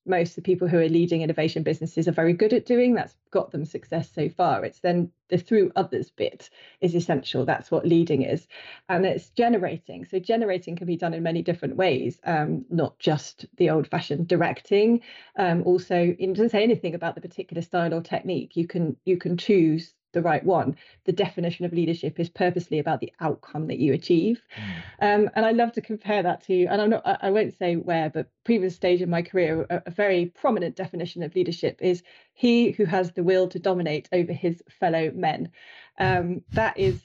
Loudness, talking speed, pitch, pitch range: -25 LUFS, 205 wpm, 175 Hz, 165-190 Hz